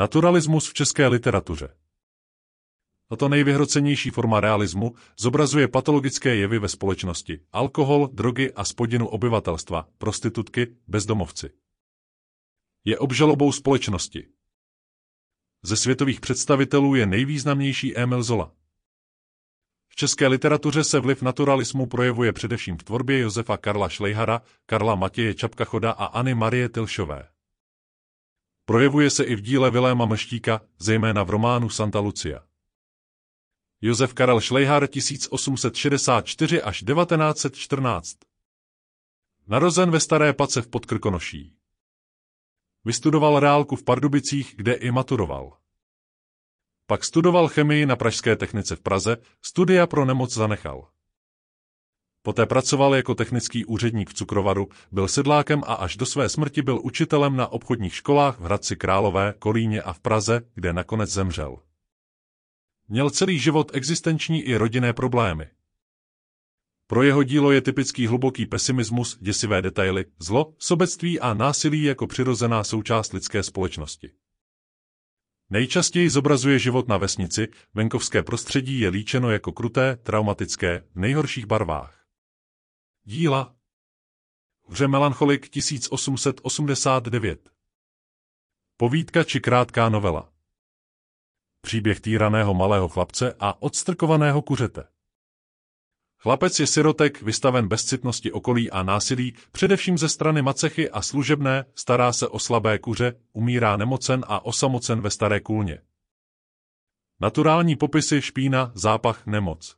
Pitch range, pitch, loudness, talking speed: 95-135 Hz, 115 Hz, -22 LUFS, 115 wpm